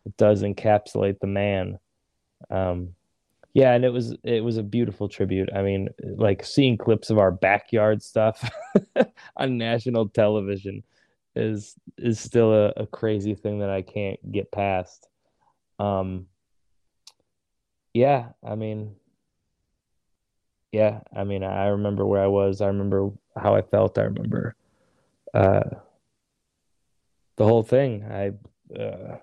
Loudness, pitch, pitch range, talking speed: -24 LUFS, 105 Hz, 100-115 Hz, 130 wpm